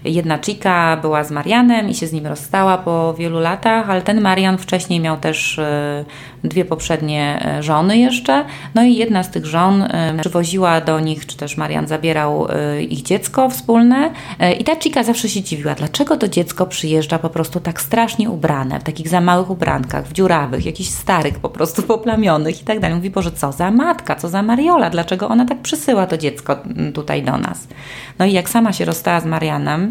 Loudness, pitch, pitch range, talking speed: -16 LUFS, 170 Hz, 155-210 Hz, 190 wpm